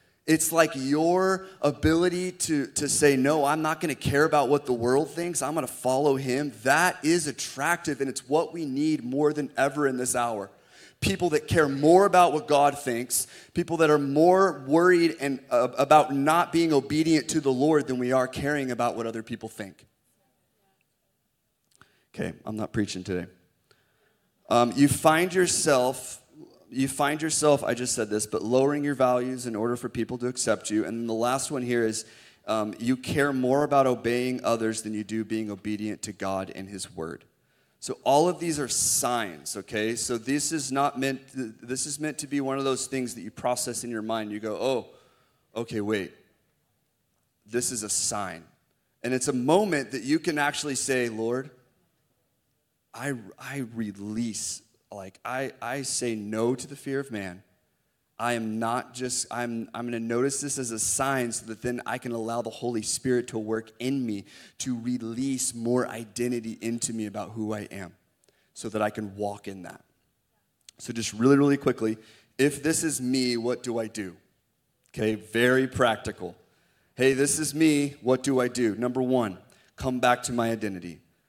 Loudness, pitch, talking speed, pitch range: -26 LUFS, 125 Hz, 185 wpm, 115-145 Hz